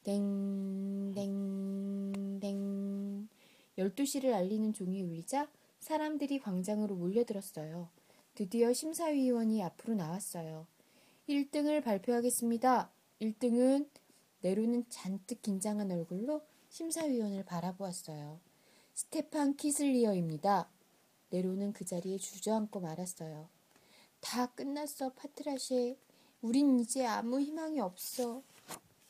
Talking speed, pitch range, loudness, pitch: 245 characters per minute, 195-265 Hz, -36 LUFS, 215 Hz